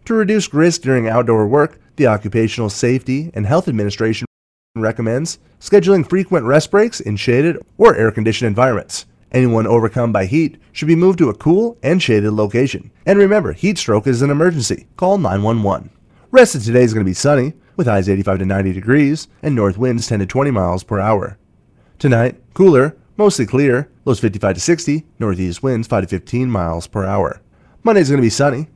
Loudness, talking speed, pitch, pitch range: -15 LUFS, 190 wpm, 125 Hz, 105-150 Hz